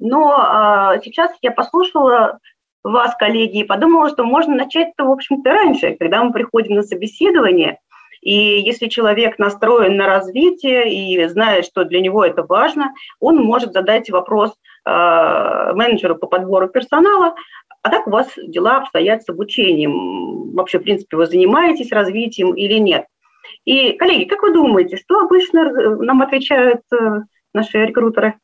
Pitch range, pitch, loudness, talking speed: 205-295 Hz, 235 Hz, -14 LUFS, 150 wpm